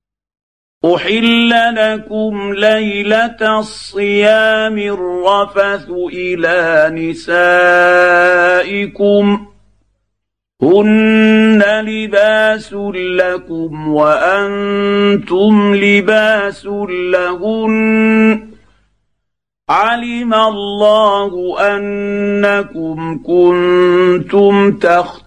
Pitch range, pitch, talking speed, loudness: 180-215 Hz, 200 Hz, 45 wpm, -12 LUFS